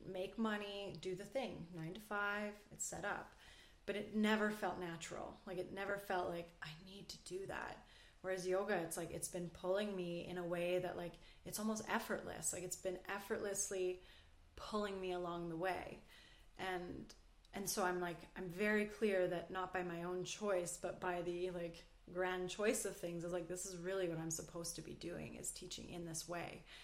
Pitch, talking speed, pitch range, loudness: 185 Hz, 200 wpm, 175-200 Hz, -43 LUFS